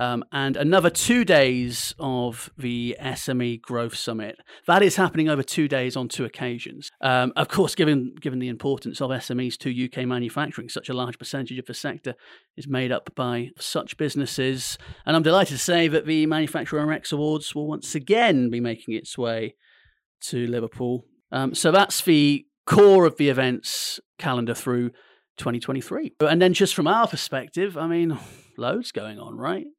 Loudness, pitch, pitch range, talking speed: -23 LUFS, 135 Hz, 125-160 Hz, 175 wpm